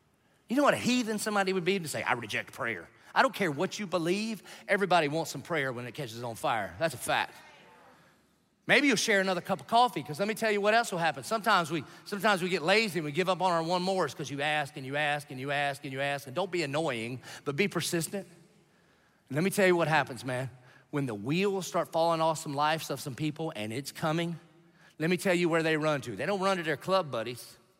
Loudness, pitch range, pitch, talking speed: -30 LUFS, 145-190 Hz, 165 Hz, 255 wpm